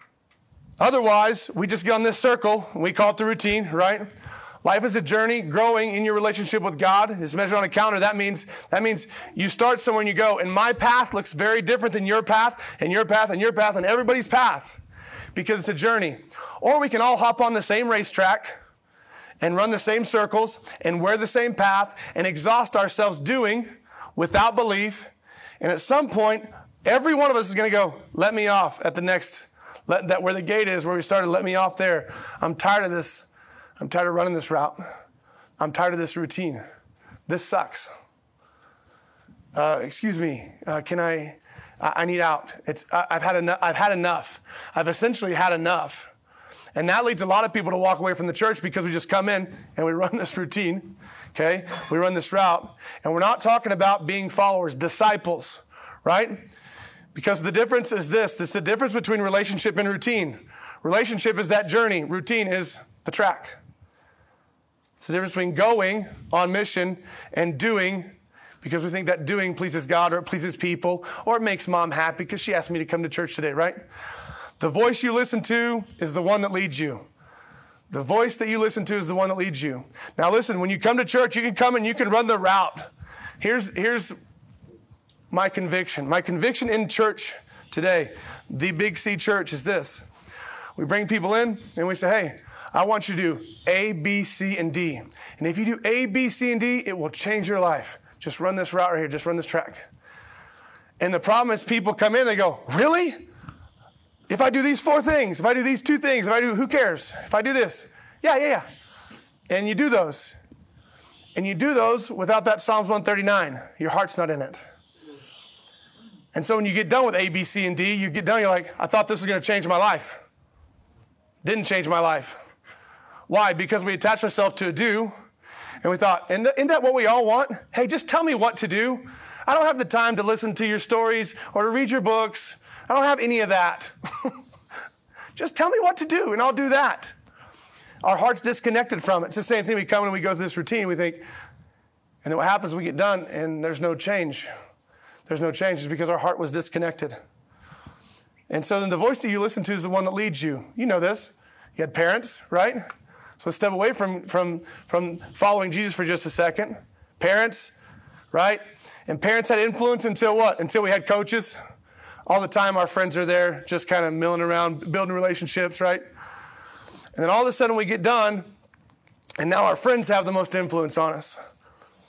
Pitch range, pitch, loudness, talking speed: 175-225 Hz, 200 Hz, -22 LUFS, 210 wpm